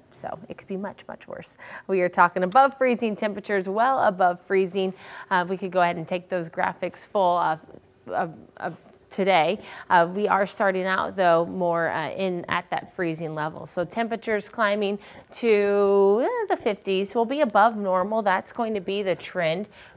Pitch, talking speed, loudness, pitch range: 190 Hz, 180 wpm, -24 LUFS, 180-210 Hz